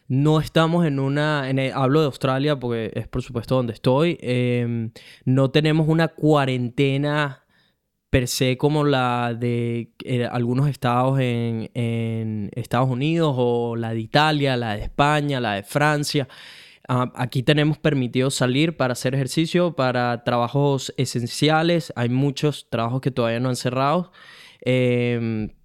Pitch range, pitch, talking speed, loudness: 120-145 Hz, 130 Hz, 145 wpm, -22 LUFS